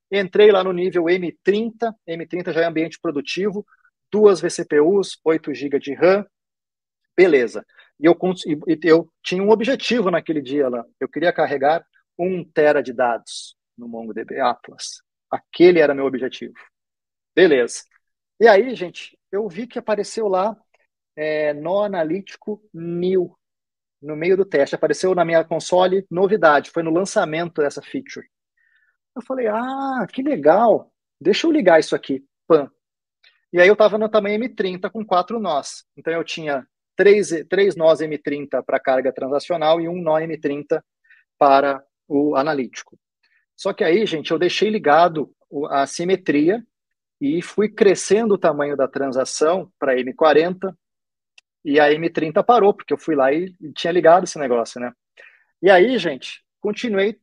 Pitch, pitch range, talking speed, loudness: 170 Hz, 150-205 Hz, 145 wpm, -19 LUFS